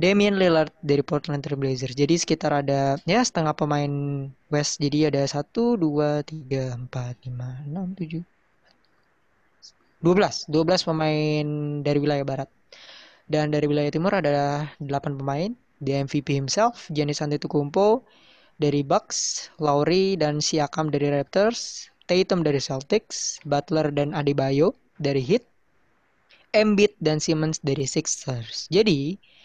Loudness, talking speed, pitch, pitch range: -24 LUFS, 125 wpm, 150 Hz, 145-165 Hz